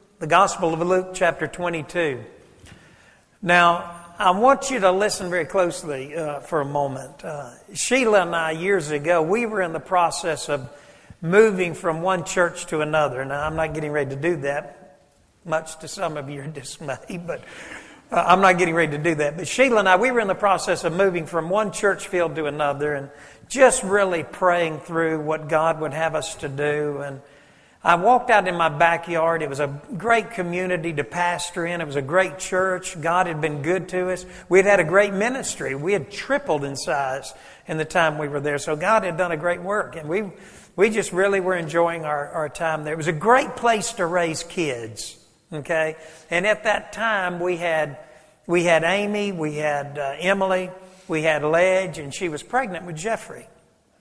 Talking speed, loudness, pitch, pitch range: 200 wpm, -22 LUFS, 170 Hz, 155-190 Hz